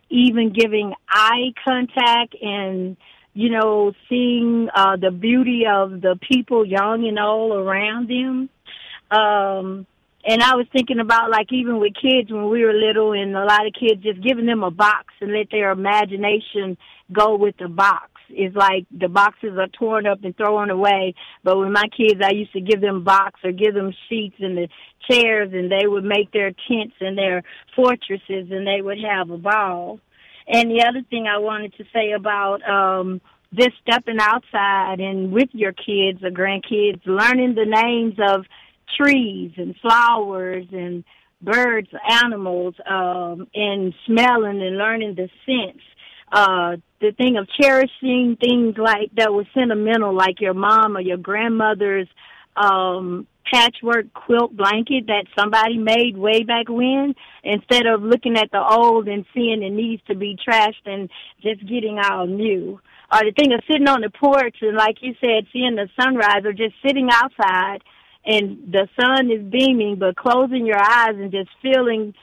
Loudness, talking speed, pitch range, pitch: -18 LUFS, 170 wpm, 195-235 Hz, 210 Hz